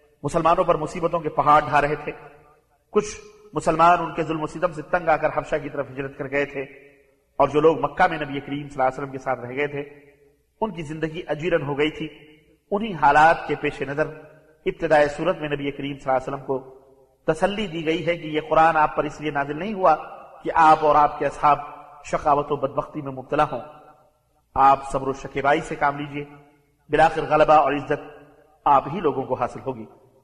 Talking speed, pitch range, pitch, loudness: 210 wpm, 140-155 Hz, 150 Hz, -22 LUFS